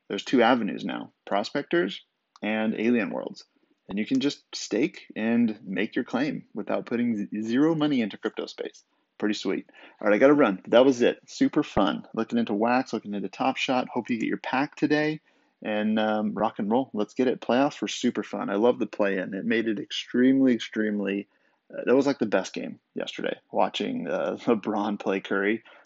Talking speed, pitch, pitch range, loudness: 195 wpm, 115 Hz, 105-135 Hz, -26 LUFS